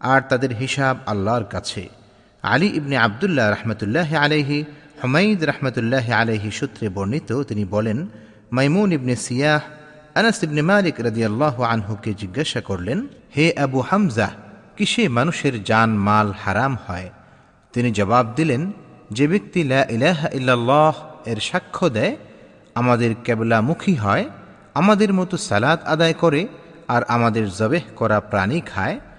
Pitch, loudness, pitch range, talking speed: 130 Hz, -20 LUFS, 110-155 Hz, 110 wpm